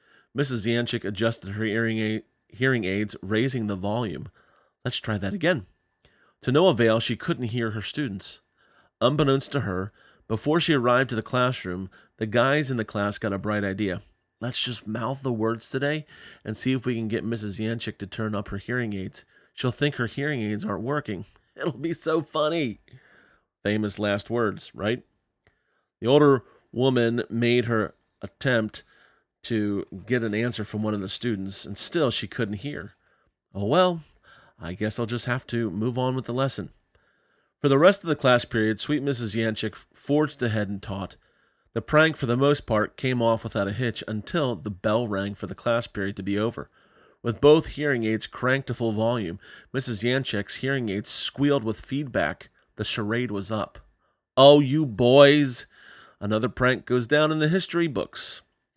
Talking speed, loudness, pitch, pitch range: 175 wpm, -25 LUFS, 115 Hz, 105-130 Hz